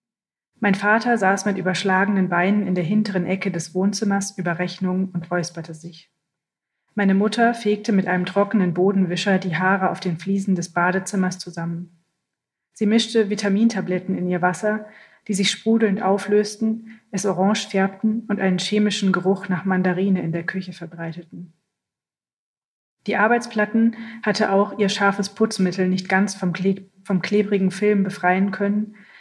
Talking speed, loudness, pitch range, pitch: 145 wpm, -21 LUFS, 180-210 Hz, 195 Hz